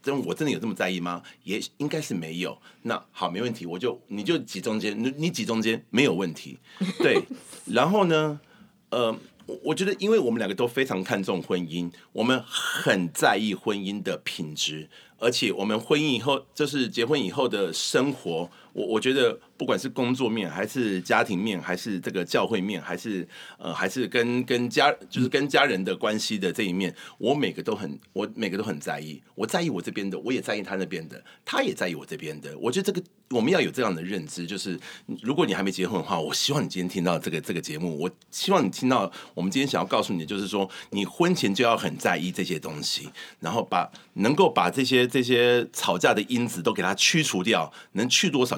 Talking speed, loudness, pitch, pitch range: 315 characters per minute, -26 LUFS, 120 Hz, 95-140 Hz